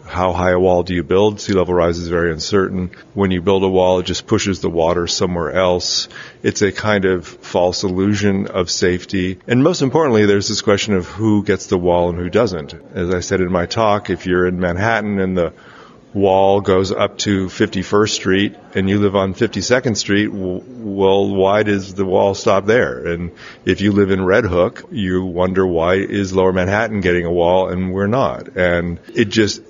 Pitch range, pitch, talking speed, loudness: 90-100 Hz, 95 Hz, 200 wpm, -16 LUFS